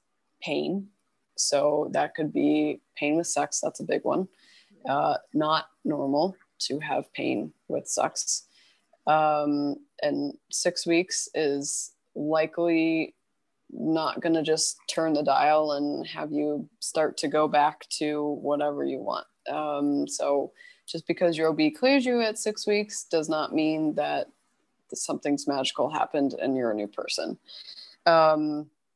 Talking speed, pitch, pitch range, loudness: 140 wpm, 155 Hz, 145-170 Hz, -27 LUFS